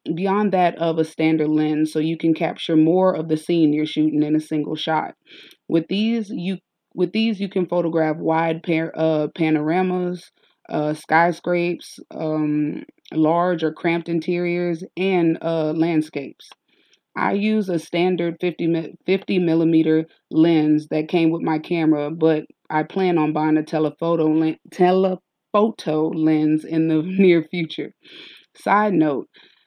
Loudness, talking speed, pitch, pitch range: -20 LUFS, 140 wpm, 165 Hz, 155-175 Hz